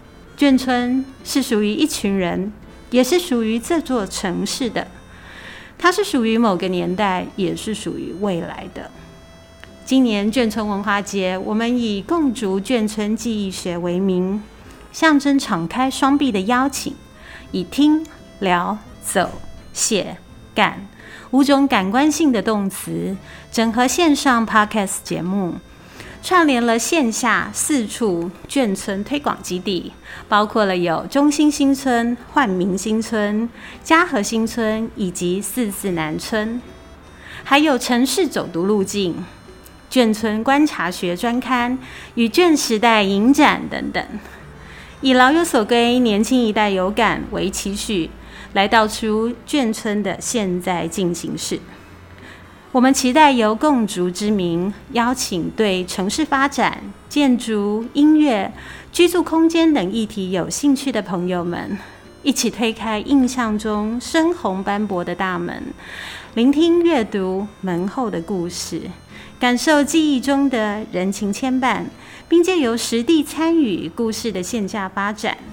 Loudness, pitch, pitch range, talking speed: -18 LUFS, 225 Hz, 195-265 Hz, 200 characters per minute